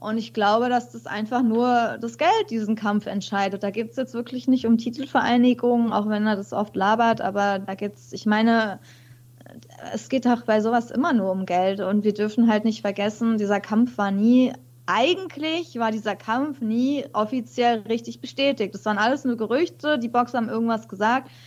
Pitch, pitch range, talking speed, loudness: 225 Hz, 205-245 Hz, 185 wpm, -23 LUFS